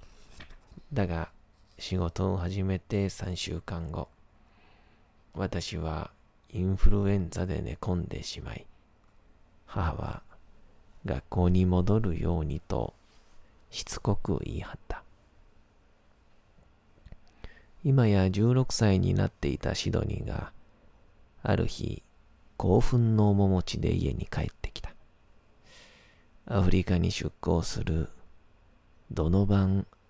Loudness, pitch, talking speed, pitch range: -30 LUFS, 95 Hz, 180 characters per minute, 85-105 Hz